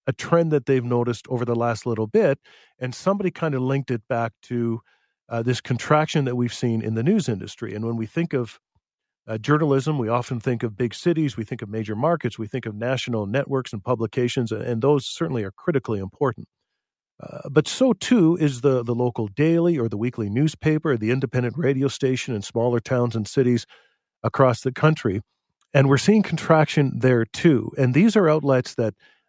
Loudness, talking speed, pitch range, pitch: -22 LUFS, 195 wpm, 115-150 Hz, 130 Hz